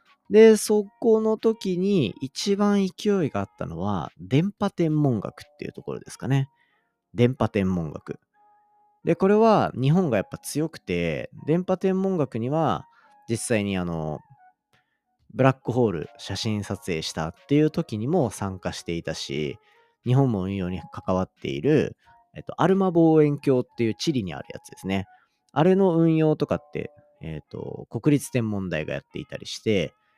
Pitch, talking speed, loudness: 145 Hz, 300 characters per minute, -24 LUFS